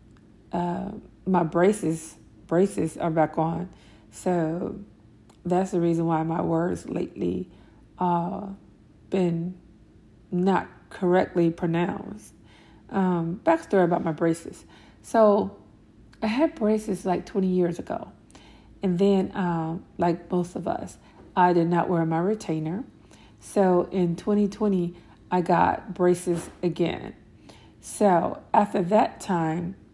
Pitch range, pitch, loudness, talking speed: 160-190 Hz, 175 Hz, -25 LUFS, 115 wpm